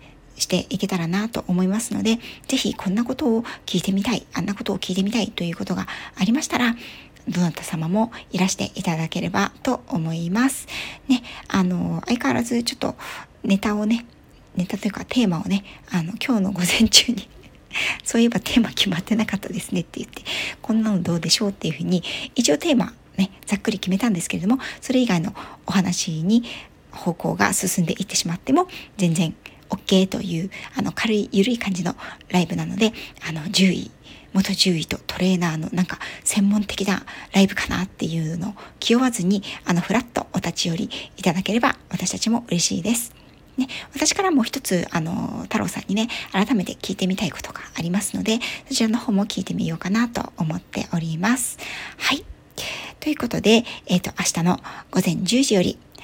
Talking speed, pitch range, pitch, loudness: 380 characters per minute, 180-230 Hz, 200 Hz, -22 LUFS